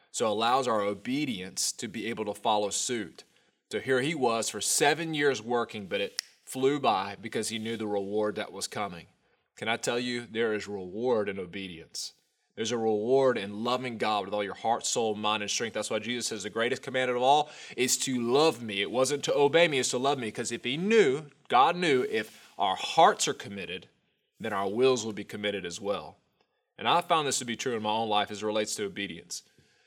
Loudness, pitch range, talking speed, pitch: -29 LUFS, 105-130 Hz, 220 wpm, 115 Hz